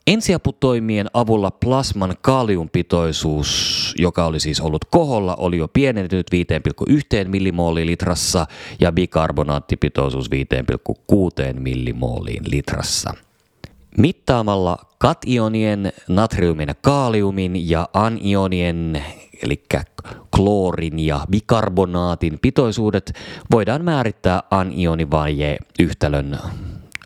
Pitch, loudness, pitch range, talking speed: 90 Hz, -19 LUFS, 80-110 Hz, 80 wpm